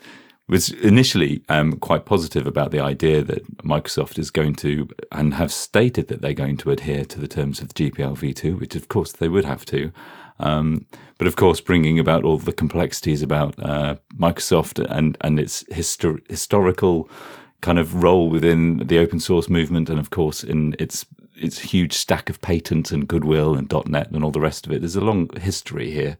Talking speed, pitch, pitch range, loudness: 195 wpm, 80 Hz, 75-85 Hz, -21 LUFS